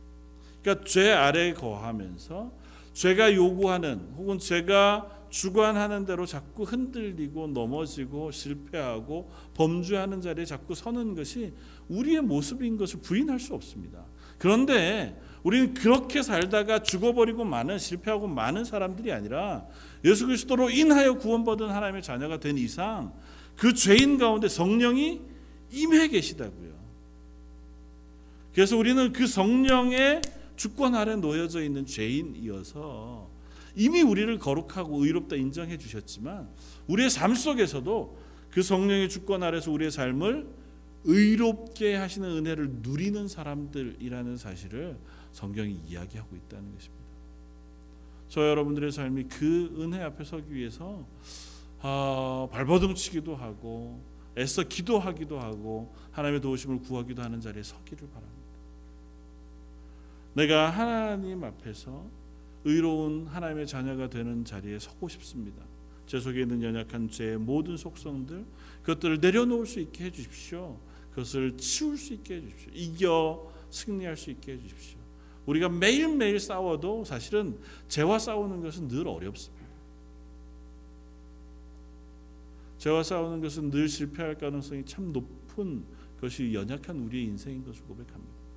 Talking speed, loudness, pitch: 305 characters per minute, -27 LUFS, 150 Hz